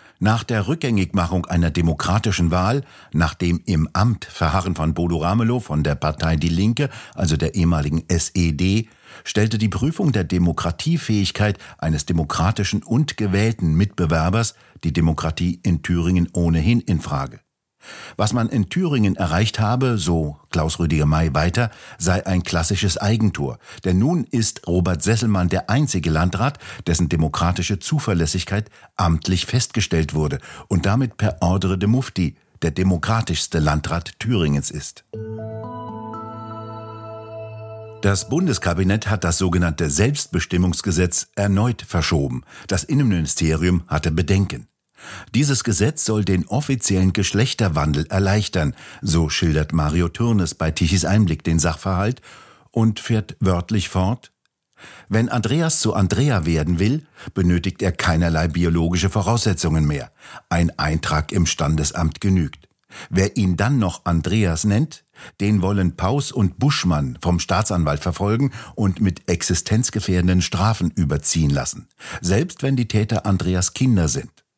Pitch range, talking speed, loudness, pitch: 85-110 Hz, 125 wpm, -20 LUFS, 95 Hz